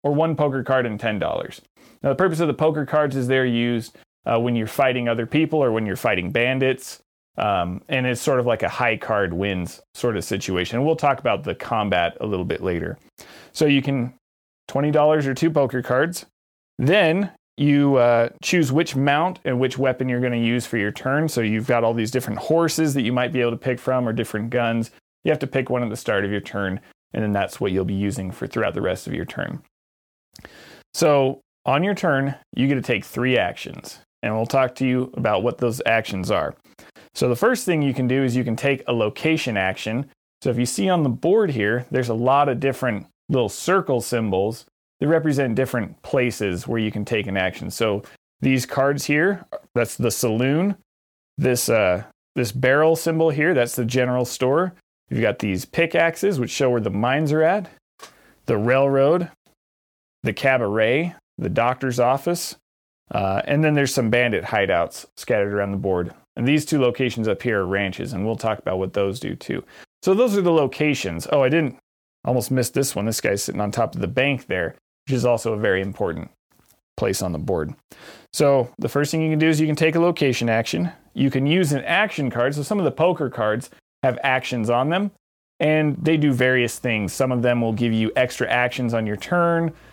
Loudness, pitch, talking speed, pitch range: -21 LUFS, 125 Hz, 210 wpm, 115-145 Hz